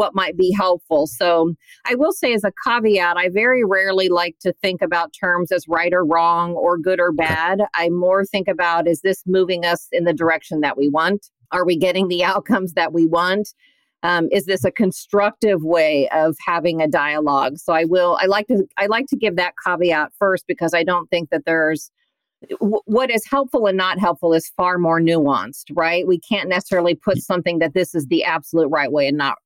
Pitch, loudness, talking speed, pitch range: 175 Hz, -18 LUFS, 210 wpm, 165-195 Hz